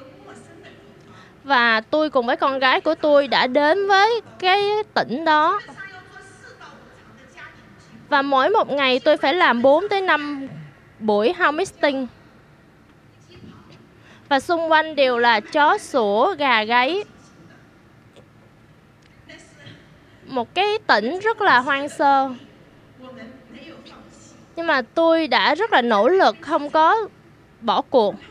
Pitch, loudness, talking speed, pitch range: 300 Hz, -18 LUFS, 115 wpm, 265-350 Hz